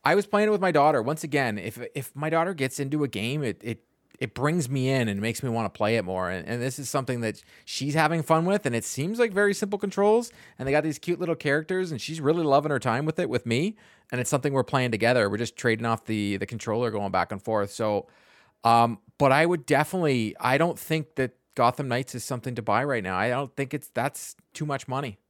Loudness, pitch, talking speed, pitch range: -26 LUFS, 135 Hz, 255 wpm, 115-155 Hz